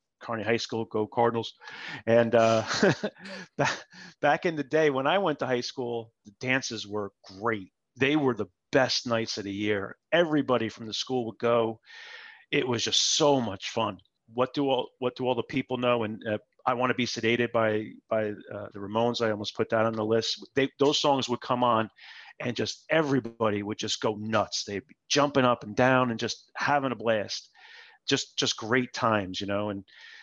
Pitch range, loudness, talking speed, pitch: 110-130 Hz, -27 LUFS, 200 wpm, 115 Hz